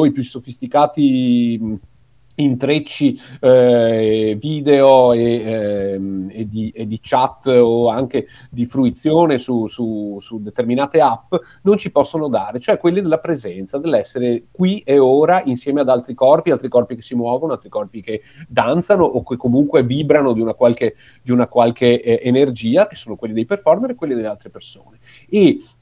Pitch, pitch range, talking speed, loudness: 125 Hz, 115-150 Hz, 165 wpm, -16 LUFS